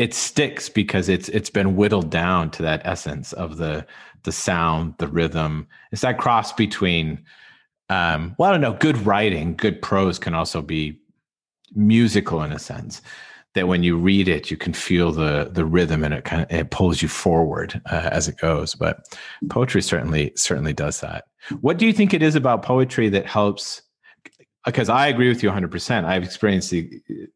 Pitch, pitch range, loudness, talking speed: 90 Hz, 80-105 Hz, -21 LUFS, 190 wpm